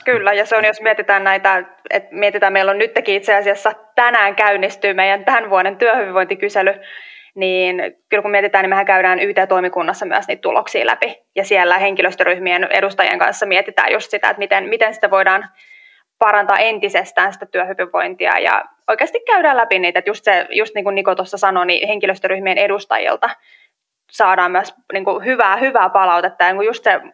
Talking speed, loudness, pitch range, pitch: 170 wpm, -15 LUFS, 190-210 Hz, 200 Hz